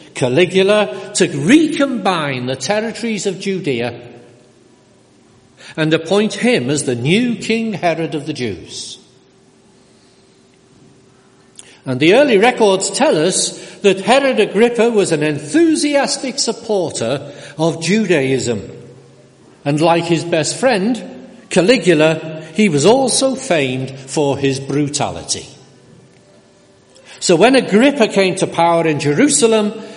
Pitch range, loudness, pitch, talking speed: 150-225 Hz, -15 LUFS, 185 Hz, 110 wpm